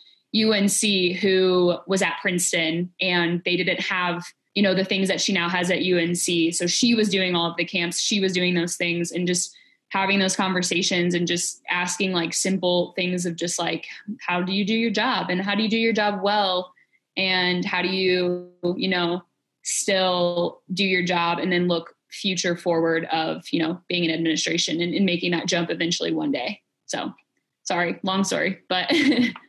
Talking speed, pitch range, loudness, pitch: 190 wpm, 175-195 Hz, -22 LUFS, 180 Hz